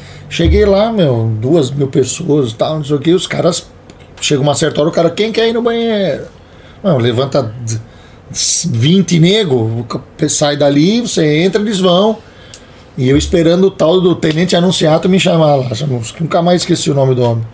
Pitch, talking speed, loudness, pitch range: 160 Hz, 180 wpm, -12 LUFS, 135-185 Hz